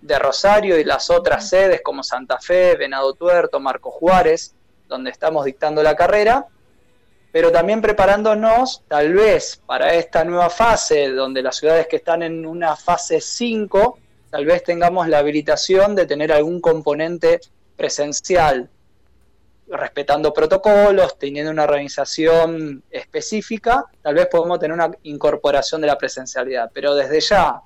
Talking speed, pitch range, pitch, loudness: 140 wpm, 150-215 Hz, 170 Hz, -17 LUFS